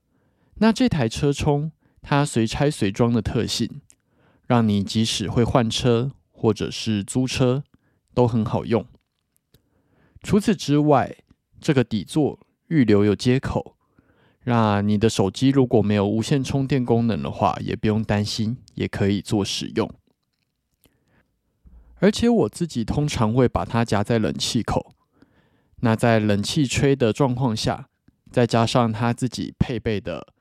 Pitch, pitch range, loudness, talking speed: 115 Hz, 105-135 Hz, -22 LUFS, 205 characters per minute